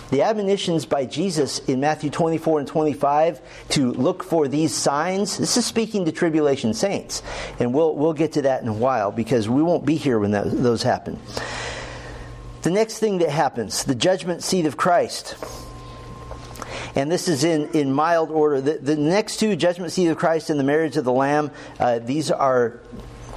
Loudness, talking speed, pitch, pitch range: -21 LUFS, 185 wpm, 155 Hz, 135-170 Hz